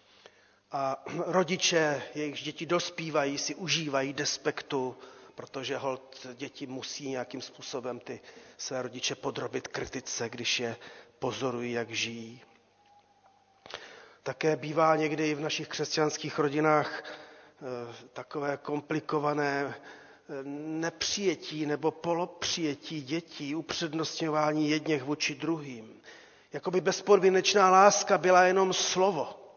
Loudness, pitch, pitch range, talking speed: -29 LUFS, 150 Hz, 140-170 Hz, 100 wpm